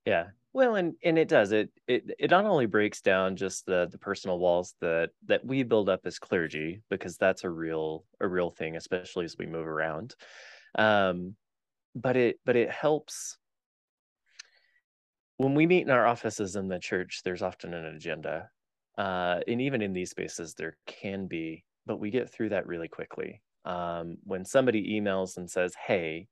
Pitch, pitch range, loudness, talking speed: 95 Hz, 85-110 Hz, -29 LUFS, 180 wpm